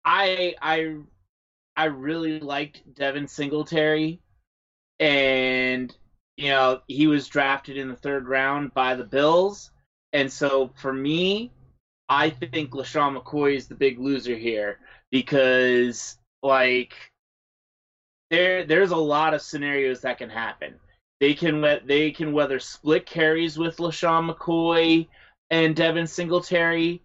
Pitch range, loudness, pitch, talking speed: 130-160 Hz, -23 LUFS, 145 Hz, 125 wpm